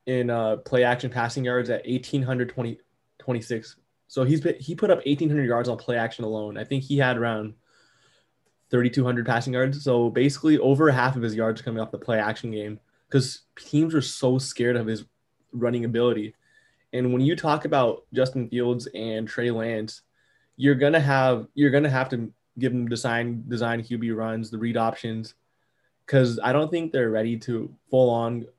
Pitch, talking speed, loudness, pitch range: 120 Hz, 185 wpm, -24 LUFS, 115-130 Hz